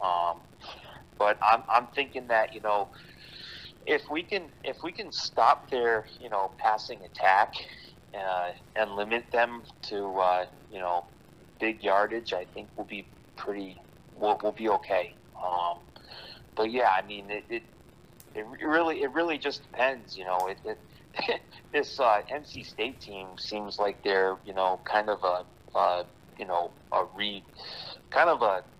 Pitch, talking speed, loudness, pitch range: 100 Hz, 165 wpm, -29 LUFS, 90-110 Hz